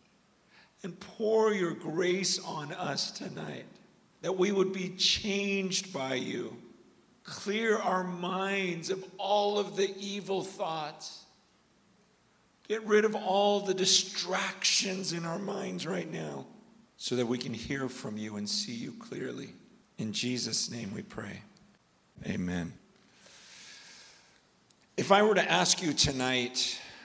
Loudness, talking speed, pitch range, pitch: -30 LUFS, 130 wpm, 155-200 Hz, 185 Hz